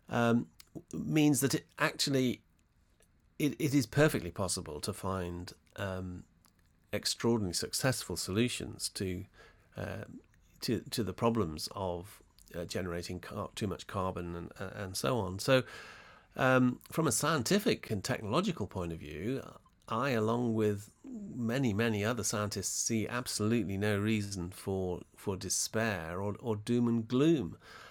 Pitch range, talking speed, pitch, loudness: 95-125 Hz, 135 wpm, 105 Hz, -33 LUFS